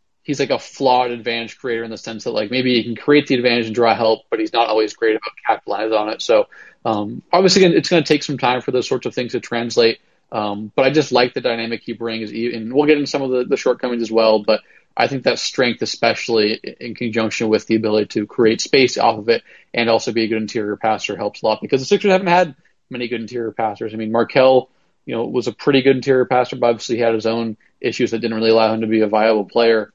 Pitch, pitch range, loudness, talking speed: 115 Hz, 110-130 Hz, -18 LUFS, 260 wpm